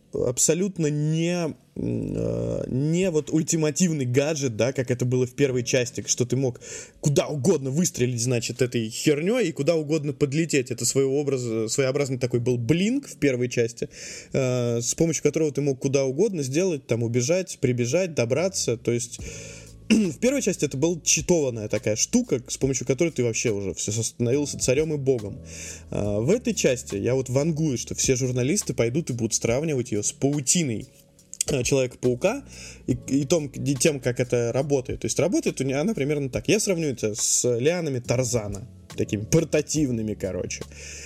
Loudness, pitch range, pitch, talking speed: -24 LUFS, 120-155 Hz, 135 Hz, 155 wpm